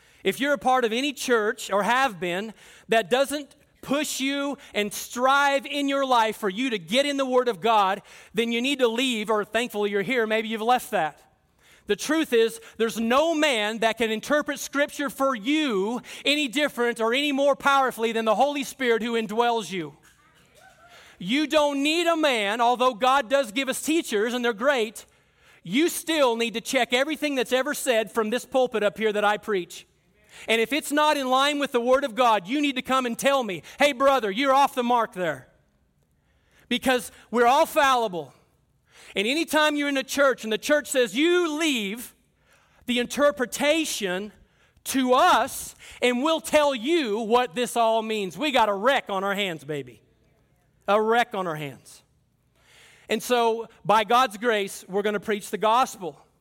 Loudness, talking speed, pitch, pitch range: -24 LUFS, 185 wpm, 240 Hz, 215-275 Hz